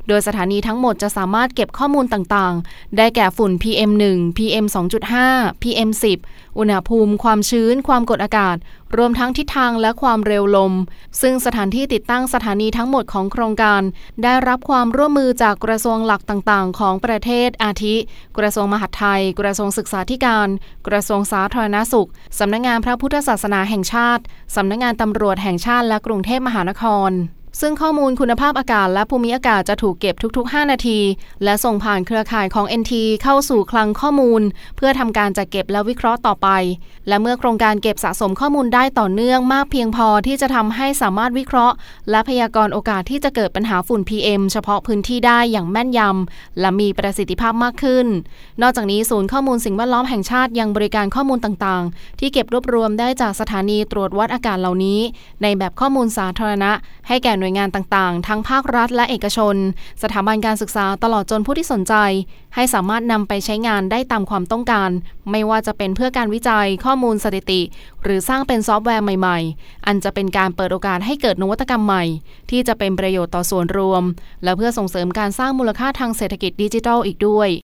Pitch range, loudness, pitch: 200-240 Hz, -17 LUFS, 215 Hz